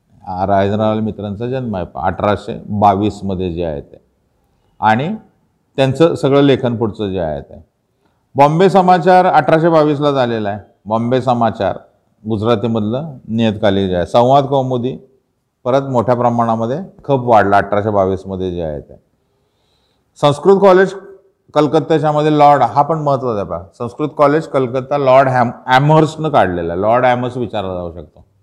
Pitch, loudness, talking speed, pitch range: 125 Hz, -14 LUFS, 130 wpm, 105-145 Hz